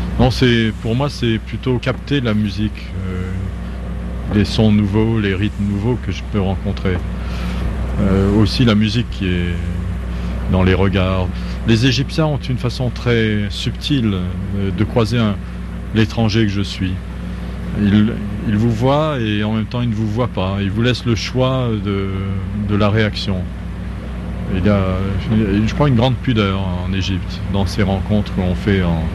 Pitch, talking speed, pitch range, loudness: 100 Hz, 170 wpm, 90-110 Hz, -18 LUFS